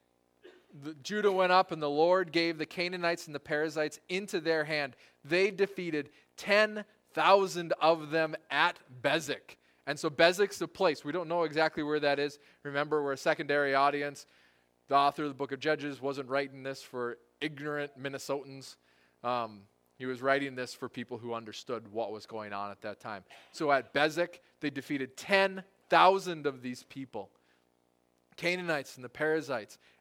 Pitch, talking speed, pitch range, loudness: 145 Hz, 165 wpm, 125-165 Hz, -31 LUFS